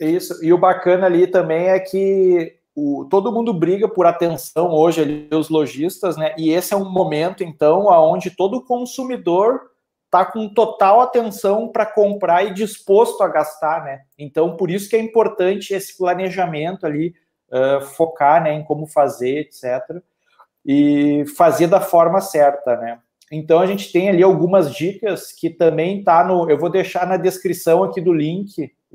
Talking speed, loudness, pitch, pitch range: 165 wpm, -17 LUFS, 180 Hz, 155-195 Hz